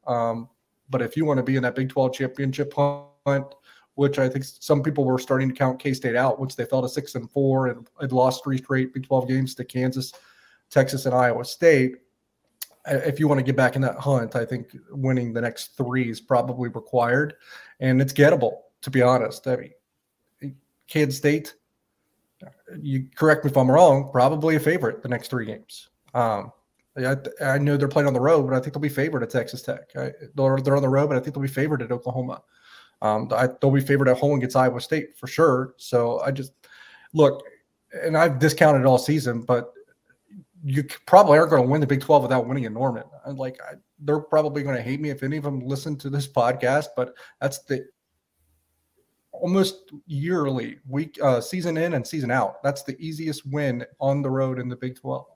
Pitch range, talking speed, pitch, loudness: 125-145 Hz, 210 wpm, 135 Hz, -23 LUFS